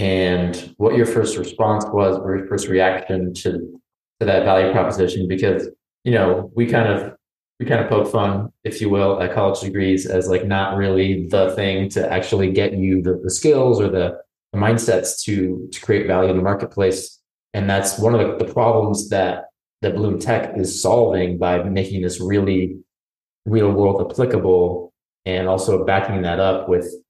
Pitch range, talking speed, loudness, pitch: 95-100 Hz, 180 wpm, -19 LUFS, 95 Hz